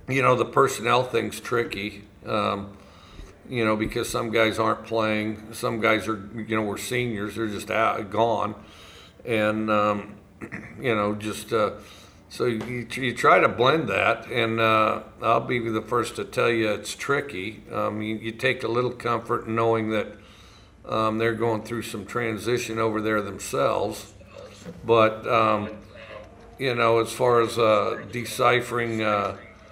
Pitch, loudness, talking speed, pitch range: 110 Hz, -24 LUFS, 155 wpm, 105-115 Hz